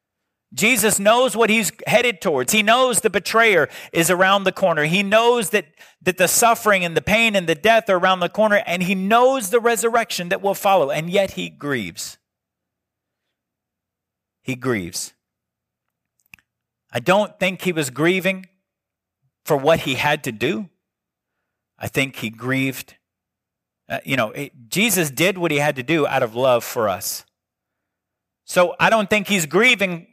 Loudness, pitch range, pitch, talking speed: -18 LUFS, 140-210 Hz, 180 Hz, 165 wpm